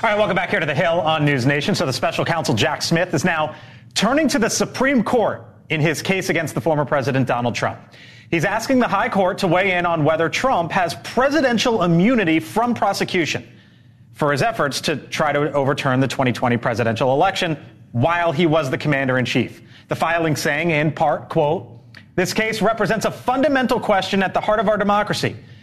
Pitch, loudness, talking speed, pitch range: 165 Hz, -19 LUFS, 200 wpm, 135-200 Hz